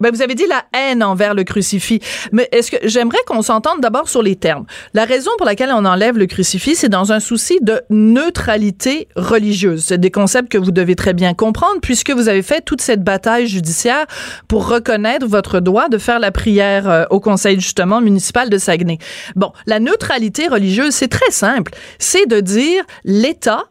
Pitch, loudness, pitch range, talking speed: 220 Hz, -14 LUFS, 195-250 Hz, 190 wpm